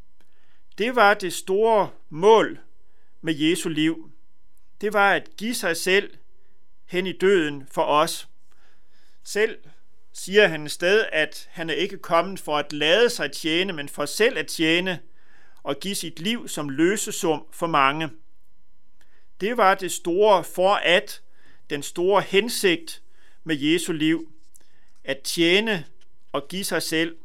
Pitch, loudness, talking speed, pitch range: 175 Hz, -22 LUFS, 145 wpm, 160-200 Hz